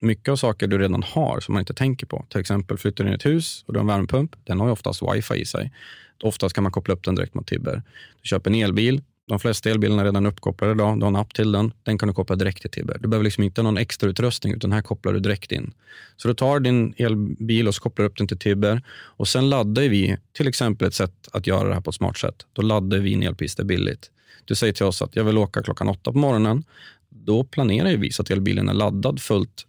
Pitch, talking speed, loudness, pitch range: 105 Hz, 265 wpm, -22 LUFS, 100-120 Hz